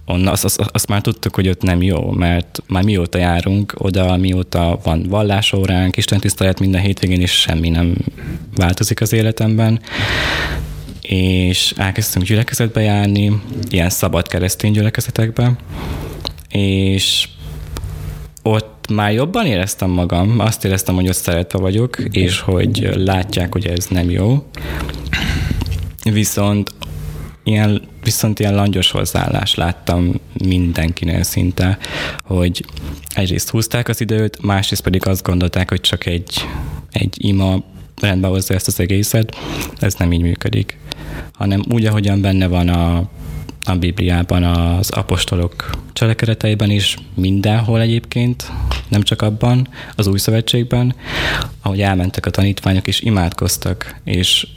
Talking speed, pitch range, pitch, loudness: 125 wpm, 85-105 Hz, 95 Hz, -16 LUFS